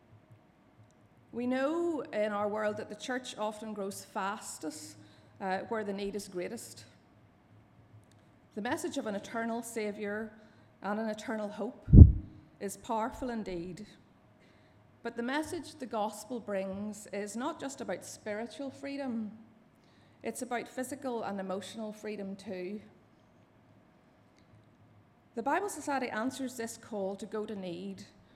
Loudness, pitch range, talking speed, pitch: -33 LUFS, 195-240 Hz, 125 wpm, 215 Hz